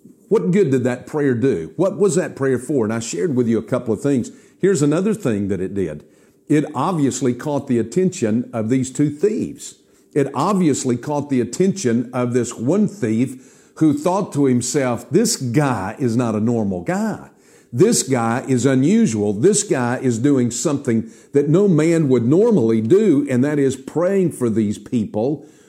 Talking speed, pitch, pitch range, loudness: 180 wpm, 130 Hz, 120-155 Hz, -18 LUFS